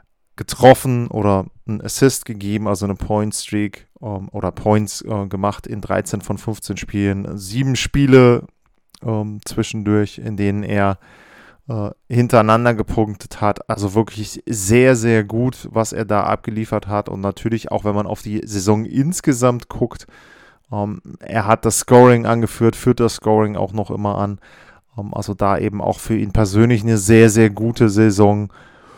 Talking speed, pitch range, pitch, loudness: 145 wpm, 105-115 Hz, 110 Hz, -17 LUFS